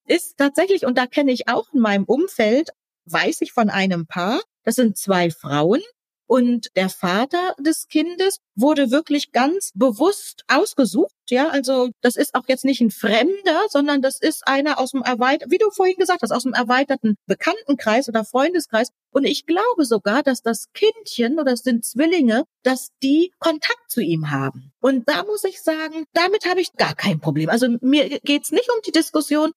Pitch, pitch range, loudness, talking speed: 270 Hz, 235-325 Hz, -19 LUFS, 185 wpm